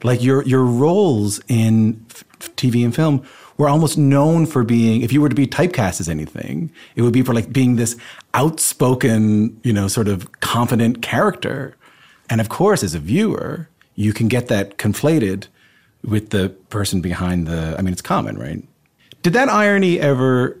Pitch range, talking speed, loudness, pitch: 105-145 Hz, 180 wpm, -17 LUFS, 120 Hz